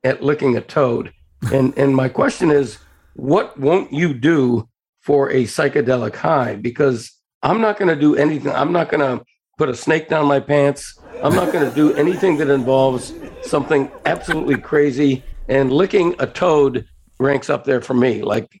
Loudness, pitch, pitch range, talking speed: -17 LUFS, 140 Hz, 125-150 Hz, 170 wpm